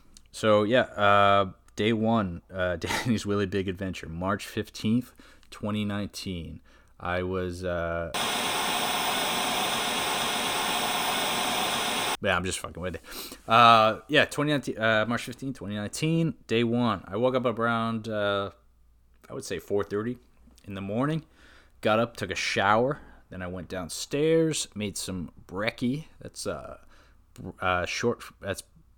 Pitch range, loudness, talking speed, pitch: 95-120 Hz, -27 LUFS, 125 wpm, 105 Hz